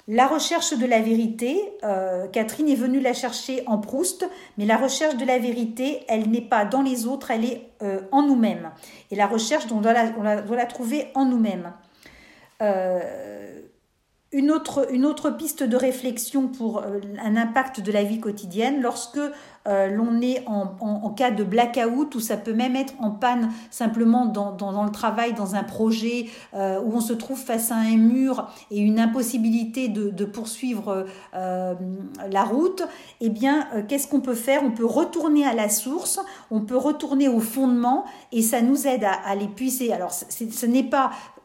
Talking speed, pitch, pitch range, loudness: 185 wpm, 235 Hz, 215-265 Hz, -23 LUFS